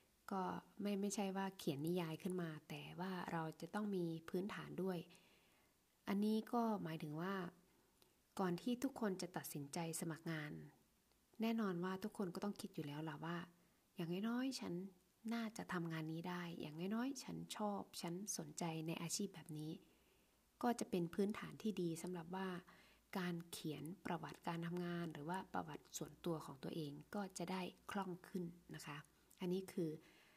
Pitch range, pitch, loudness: 165-200 Hz, 180 Hz, -46 LUFS